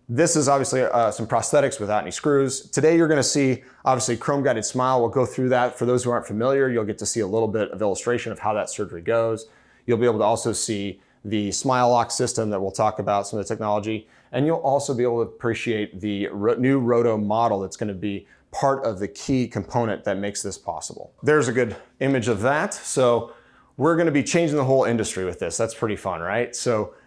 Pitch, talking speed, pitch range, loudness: 120 Hz, 235 wpm, 105-135 Hz, -23 LUFS